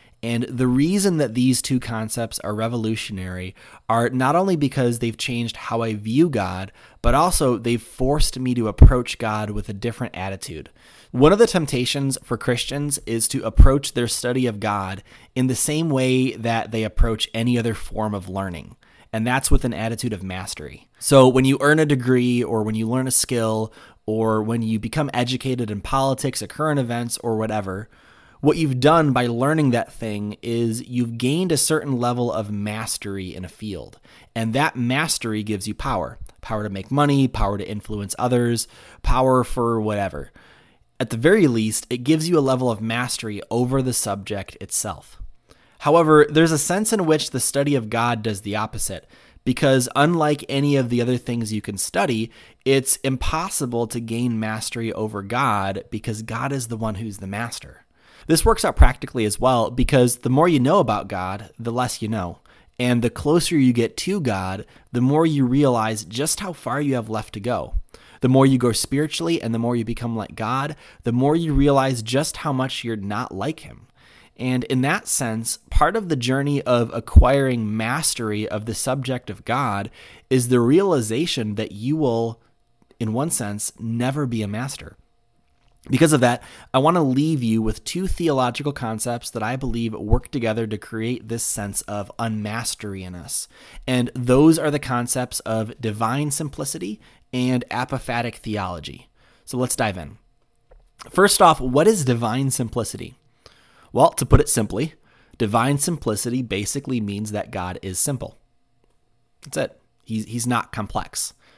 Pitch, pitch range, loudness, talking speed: 120 Hz, 110-135 Hz, -21 LUFS, 175 wpm